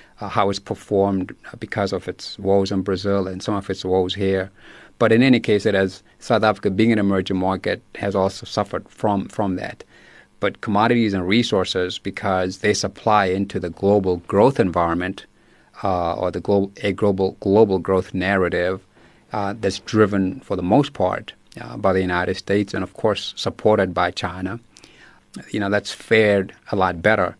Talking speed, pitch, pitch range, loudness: 175 wpm, 95 Hz, 95-105 Hz, -20 LUFS